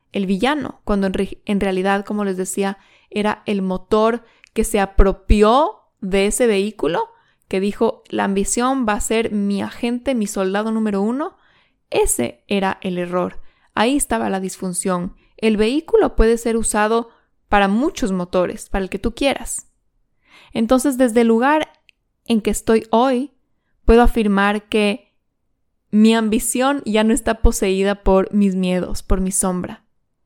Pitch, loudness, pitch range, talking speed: 215 Hz, -19 LUFS, 195-235 Hz, 150 wpm